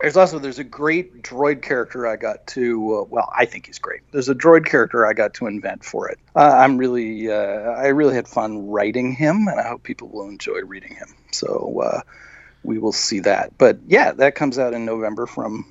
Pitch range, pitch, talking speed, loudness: 120-155 Hz, 135 Hz, 220 wpm, -19 LUFS